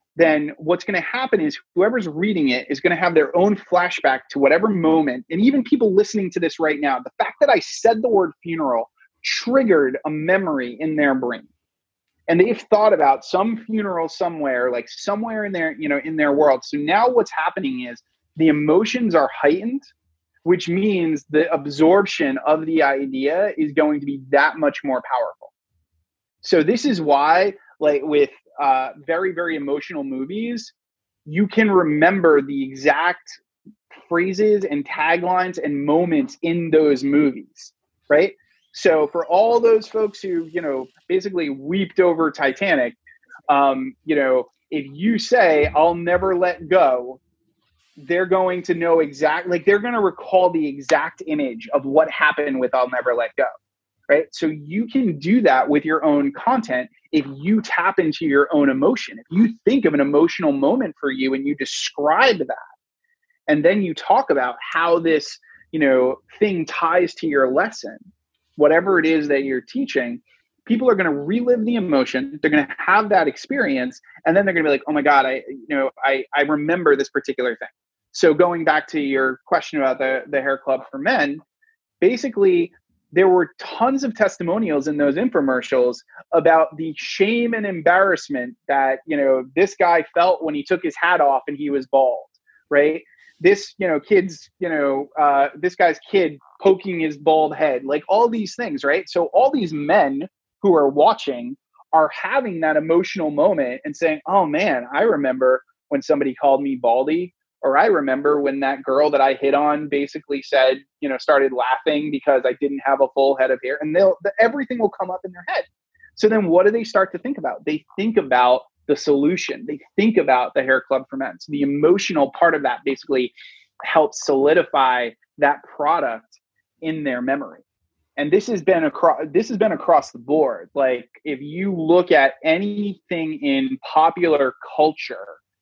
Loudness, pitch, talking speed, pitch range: -19 LUFS, 160 Hz, 180 wpm, 140-200 Hz